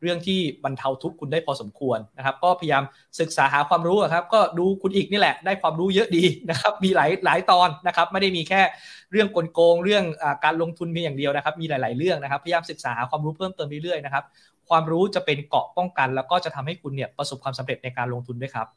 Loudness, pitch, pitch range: -23 LUFS, 165 Hz, 140-180 Hz